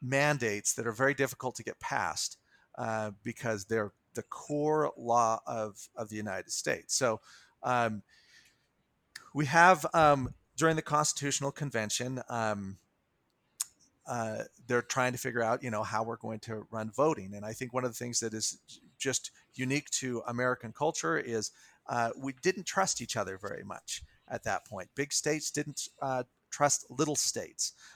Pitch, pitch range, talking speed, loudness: 125 Hz, 110-145 Hz, 165 wpm, -32 LUFS